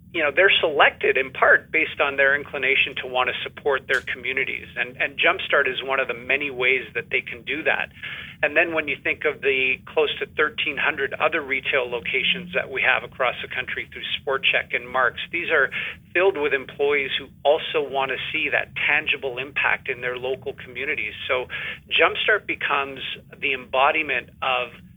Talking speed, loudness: 185 wpm, -22 LUFS